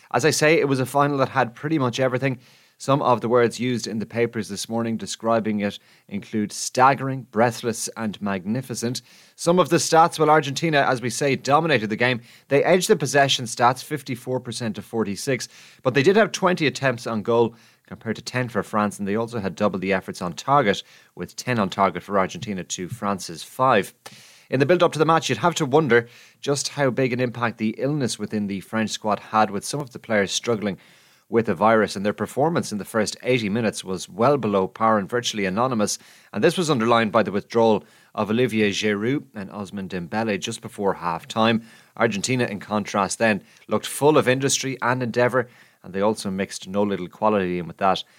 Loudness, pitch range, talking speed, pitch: -22 LUFS, 105-130 Hz, 205 wpm, 115 Hz